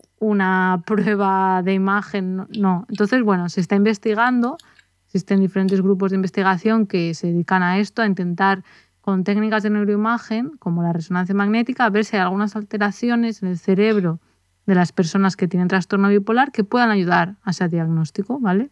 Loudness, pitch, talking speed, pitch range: -19 LUFS, 195 Hz, 170 wpm, 185-215 Hz